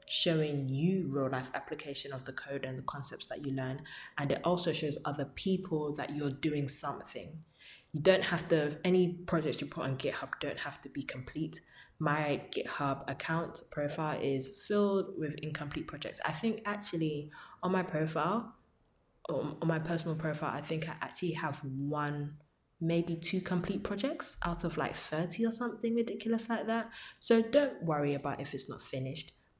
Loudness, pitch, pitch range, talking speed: -35 LUFS, 155 Hz, 140-180 Hz, 170 wpm